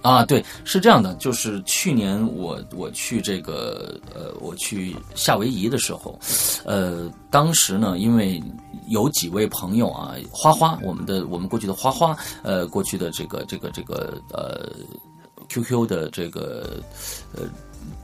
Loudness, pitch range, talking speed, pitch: -22 LUFS, 95-140 Hz, 215 characters per minute, 115 Hz